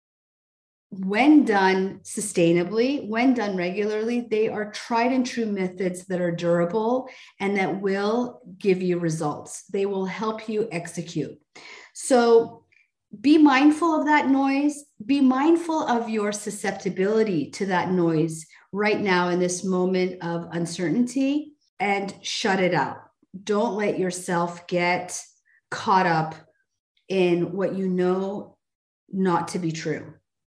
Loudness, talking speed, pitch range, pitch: -23 LUFS, 130 wpm, 180-235 Hz, 195 Hz